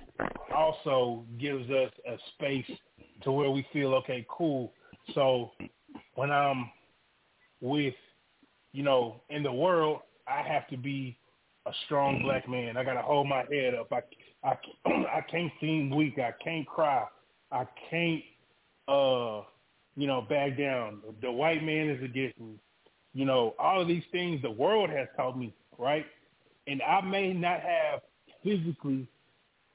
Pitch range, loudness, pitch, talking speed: 130-155 Hz, -31 LUFS, 140 Hz, 150 wpm